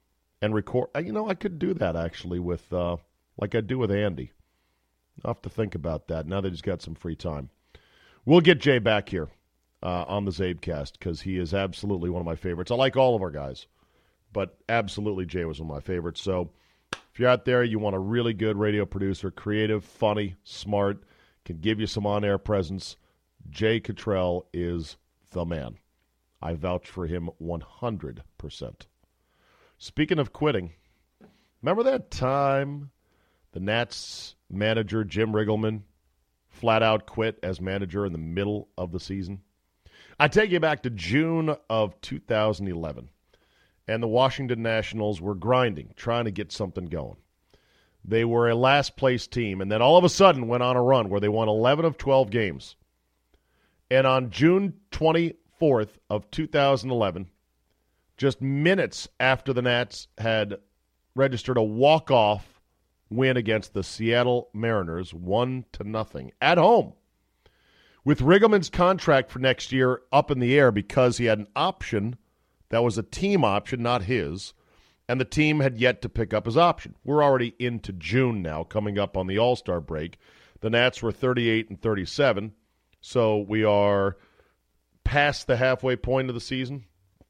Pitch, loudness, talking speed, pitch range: 105 Hz, -25 LUFS, 165 wpm, 90-125 Hz